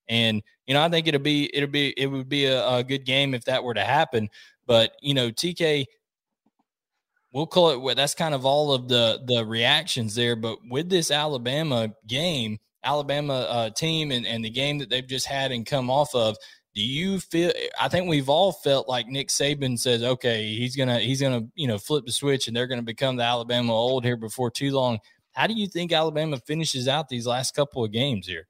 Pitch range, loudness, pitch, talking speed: 120-145 Hz, -24 LUFS, 130 Hz, 225 wpm